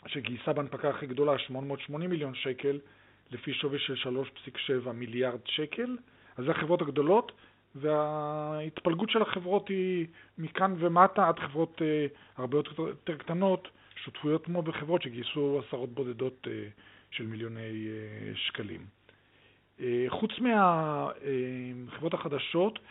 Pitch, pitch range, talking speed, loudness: 145 Hz, 125-170 Hz, 105 wpm, -31 LUFS